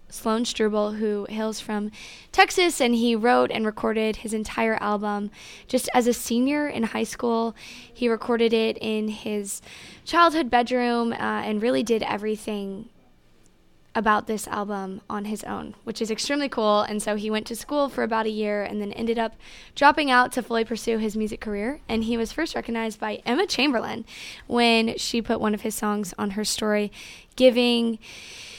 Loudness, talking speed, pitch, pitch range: -24 LUFS, 175 wpm, 225 Hz, 215-240 Hz